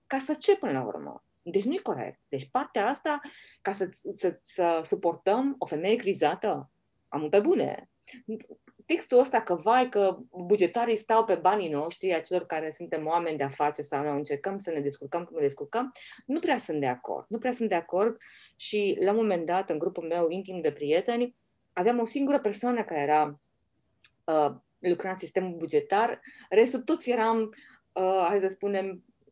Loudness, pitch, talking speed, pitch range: -28 LUFS, 195 Hz, 180 wpm, 170-240 Hz